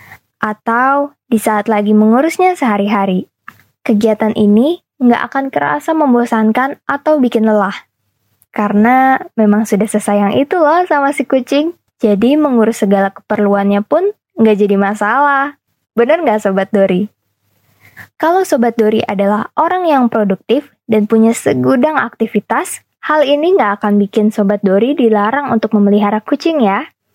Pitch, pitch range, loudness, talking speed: 220 Hz, 205-275 Hz, -12 LUFS, 130 wpm